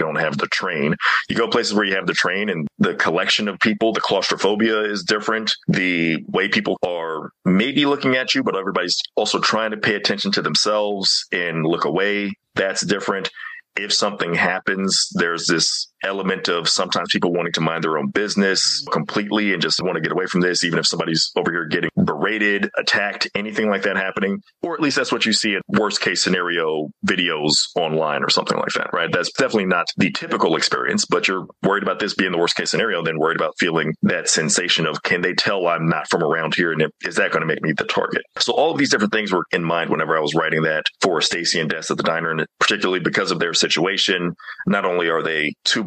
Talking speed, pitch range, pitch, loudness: 220 wpm, 85-105 Hz, 95 Hz, -19 LUFS